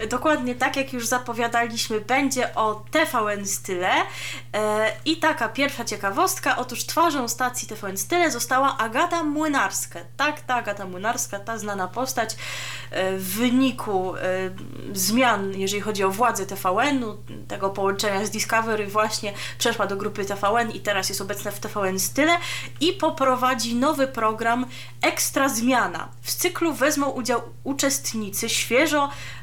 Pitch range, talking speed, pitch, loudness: 200-265 Hz, 130 wpm, 230 Hz, -23 LUFS